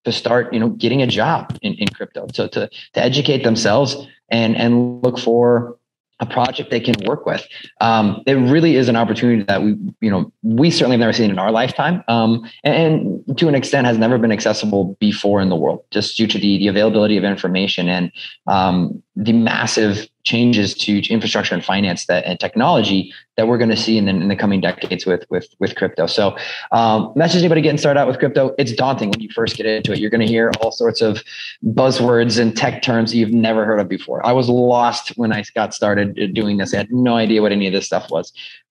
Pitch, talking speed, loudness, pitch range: 115 Hz, 225 wpm, -16 LUFS, 105-125 Hz